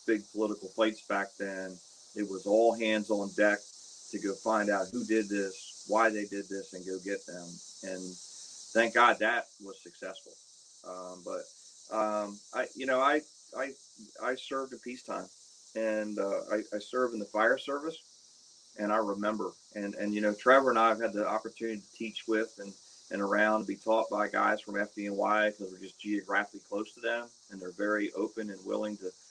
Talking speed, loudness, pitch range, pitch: 190 wpm, -31 LUFS, 100-110 Hz, 105 Hz